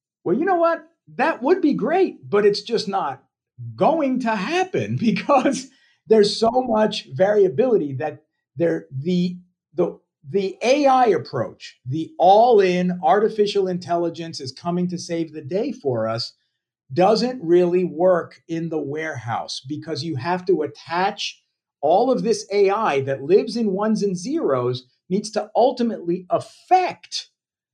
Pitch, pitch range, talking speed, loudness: 190 Hz, 160-230 Hz, 140 wpm, -21 LUFS